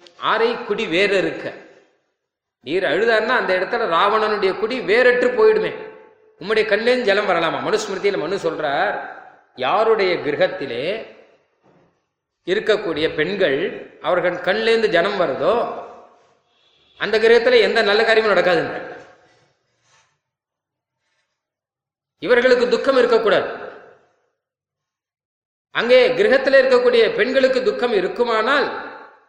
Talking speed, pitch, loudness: 85 wpm, 260 Hz, -17 LUFS